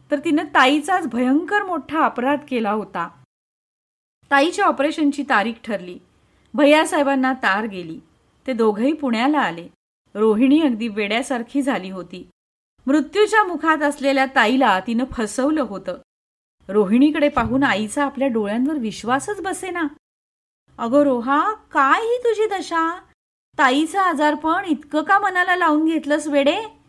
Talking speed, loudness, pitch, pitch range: 120 wpm, -19 LUFS, 280 Hz, 245-320 Hz